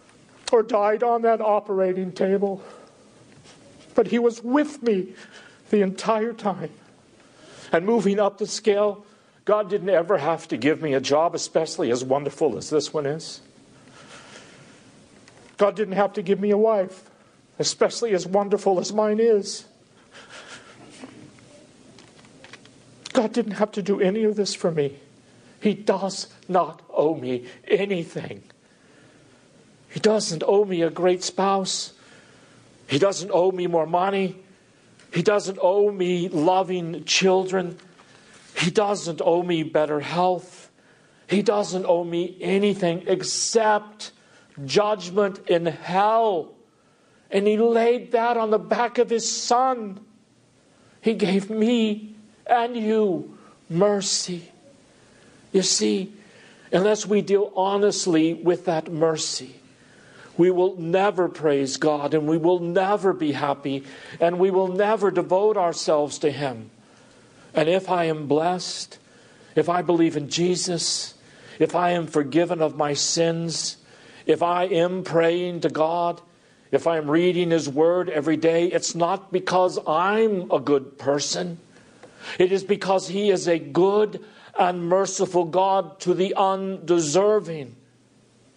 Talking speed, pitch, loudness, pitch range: 130 wpm, 185 Hz, -22 LUFS, 165-205 Hz